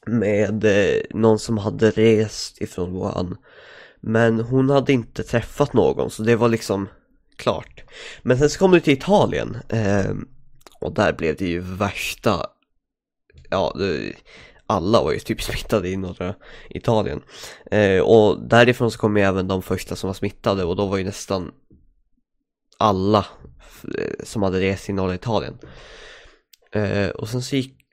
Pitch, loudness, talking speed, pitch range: 110 Hz, -21 LUFS, 155 wpm, 95-120 Hz